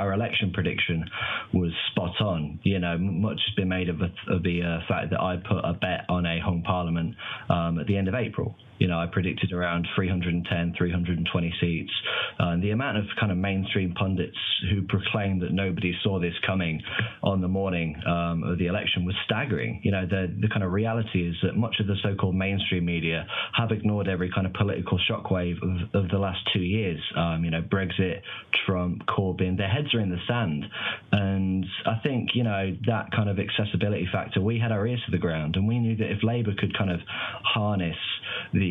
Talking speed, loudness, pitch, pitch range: 210 wpm, -27 LUFS, 95 Hz, 90-105 Hz